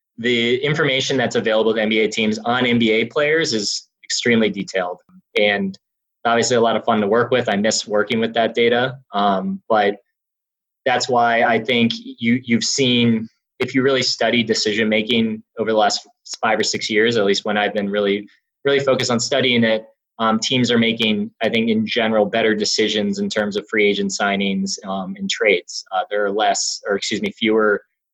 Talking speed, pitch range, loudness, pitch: 190 wpm, 105-130 Hz, -18 LUFS, 115 Hz